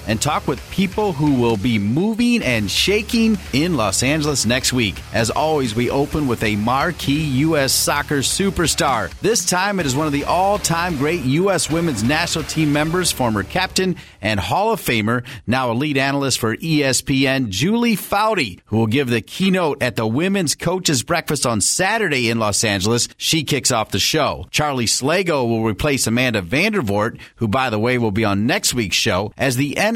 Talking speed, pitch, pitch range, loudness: 185 wpm, 135 Hz, 115-165 Hz, -18 LUFS